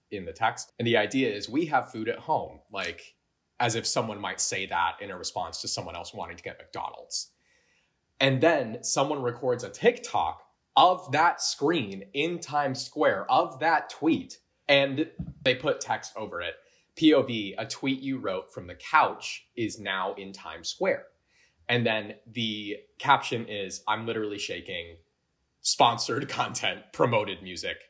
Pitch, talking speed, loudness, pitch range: 120 Hz, 160 wpm, -28 LUFS, 105-140 Hz